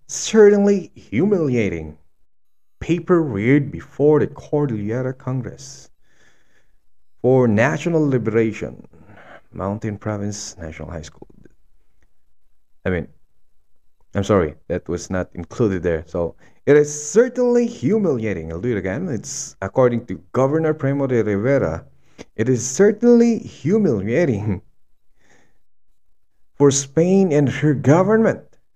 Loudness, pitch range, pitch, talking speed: -19 LUFS, 90-150 Hz, 115 Hz, 105 wpm